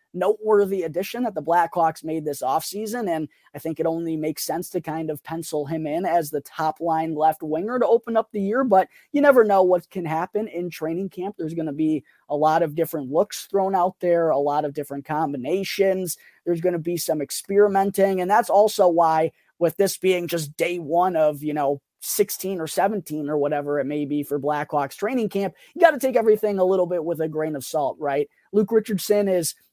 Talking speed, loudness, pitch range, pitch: 215 wpm, -23 LUFS, 155-195 Hz, 170 Hz